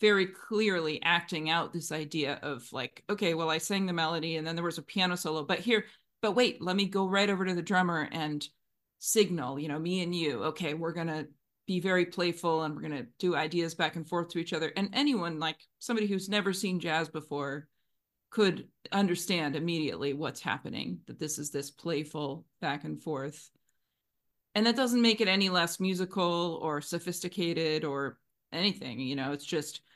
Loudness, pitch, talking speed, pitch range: -31 LUFS, 170 Hz, 195 wpm, 155-190 Hz